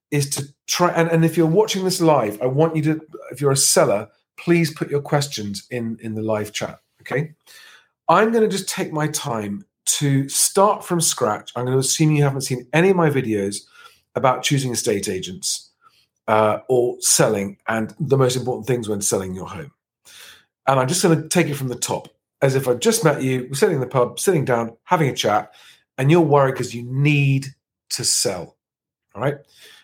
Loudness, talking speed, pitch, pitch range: -20 LUFS, 205 wpm, 140 Hz, 125-165 Hz